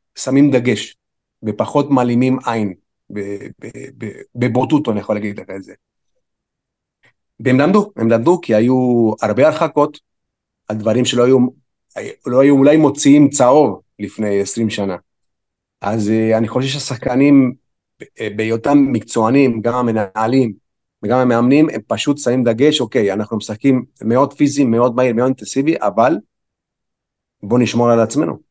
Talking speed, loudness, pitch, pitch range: 130 wpm, -15 LUFS, 125 Hz, 110-135 Hz